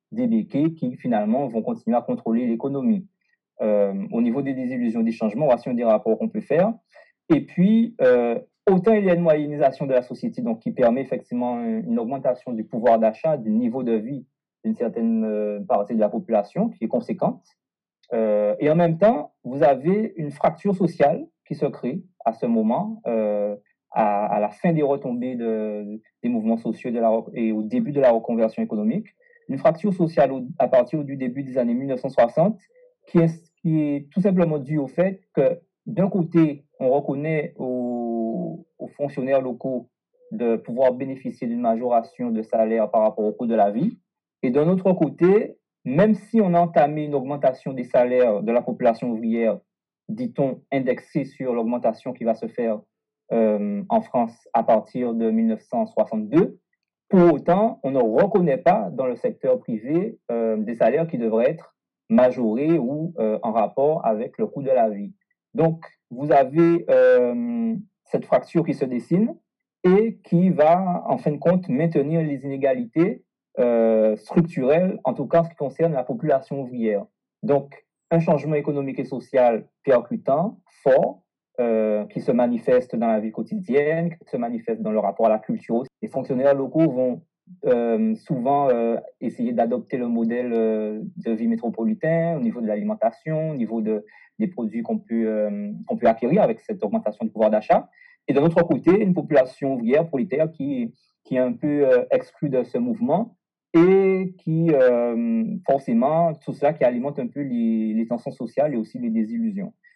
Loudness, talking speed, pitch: -22 LUFS, 175 wpm, 155 Hz